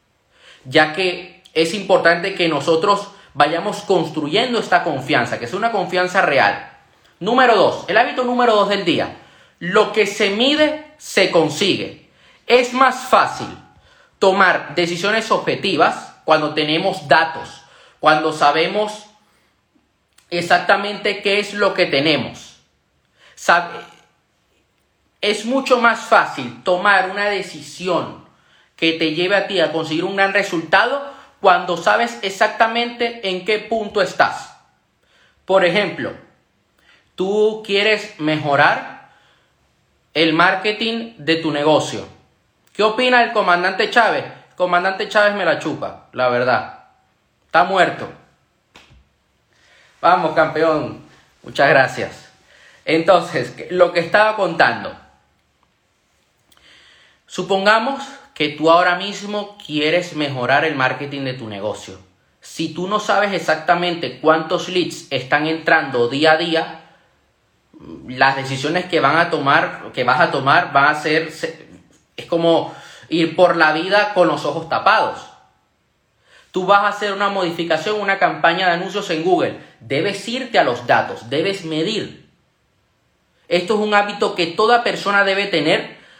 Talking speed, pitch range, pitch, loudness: 125 wpm, 160-205 Hz, 180 Hz, -17 LUFS